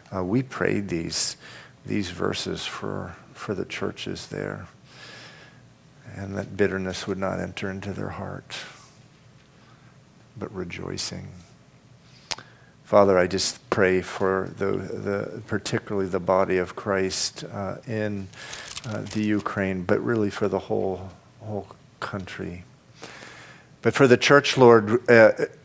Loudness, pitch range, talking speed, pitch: -24 LUFS, 95-125 Hz, 120 wpm, 105 Hz